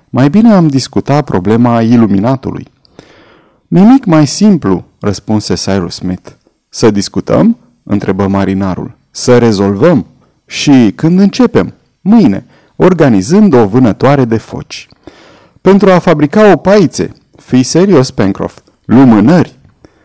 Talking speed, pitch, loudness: 110 wpm, 130 Hz, -8 LUFS